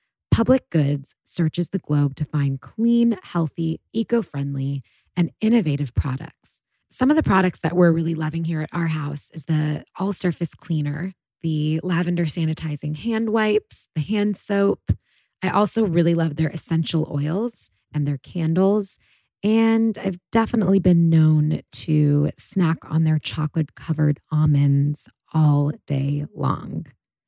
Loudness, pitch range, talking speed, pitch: -22 LUFS, 150-190 Hz, 135 wpm, 160 Hz